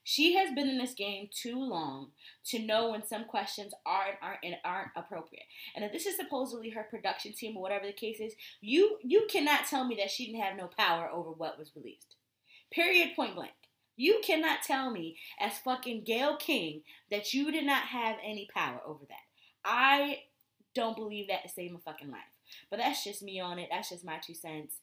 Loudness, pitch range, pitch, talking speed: -33 LUFS, 190-275 Hz, 220 Hz, 210 wpm